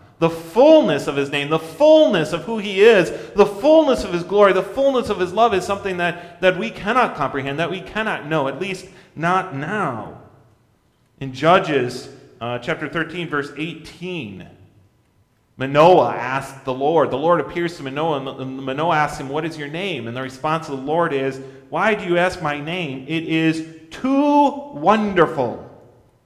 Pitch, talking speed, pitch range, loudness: 165 Hz, 175 wpm, 140-195 Hz, -19 LUFS